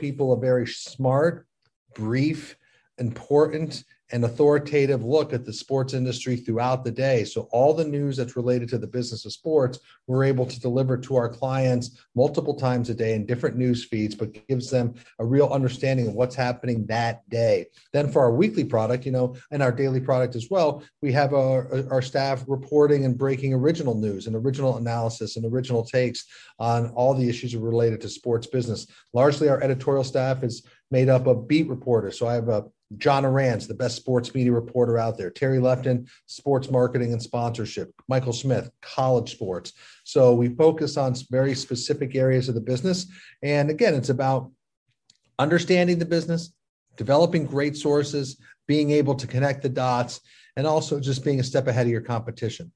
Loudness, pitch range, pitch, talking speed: -24 LUFS, 120-140 Hz, 130 Hz, 180 wpm